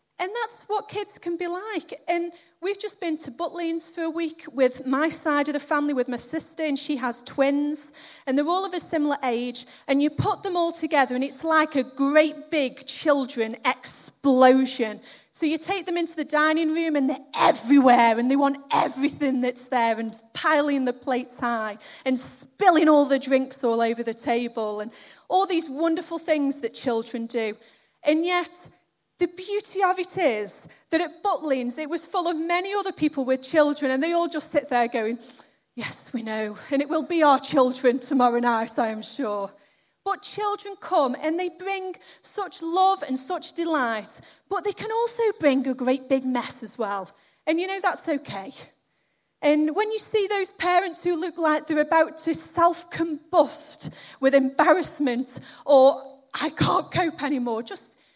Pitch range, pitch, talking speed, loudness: 260-340 Hz, 300 Hz, 185 wpm, -24 LUFS